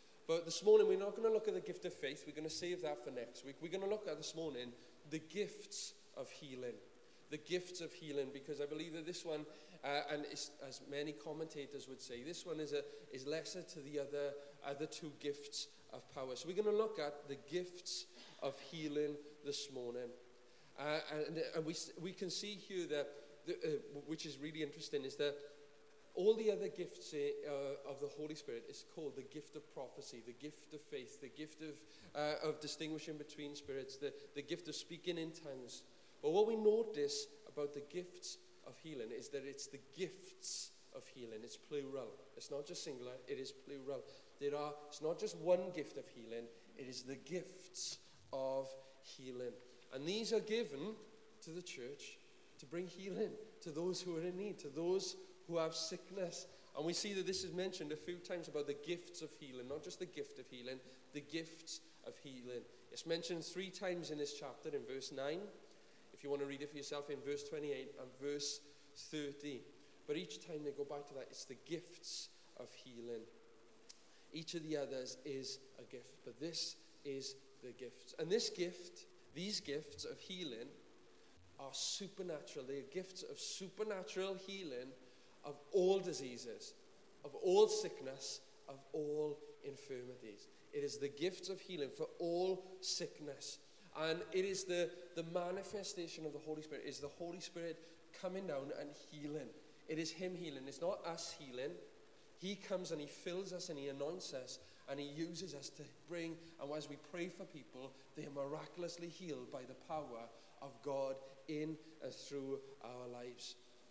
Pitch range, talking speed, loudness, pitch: 145-185 Hz, 190 wpm, -45 LUFS, 155 Hz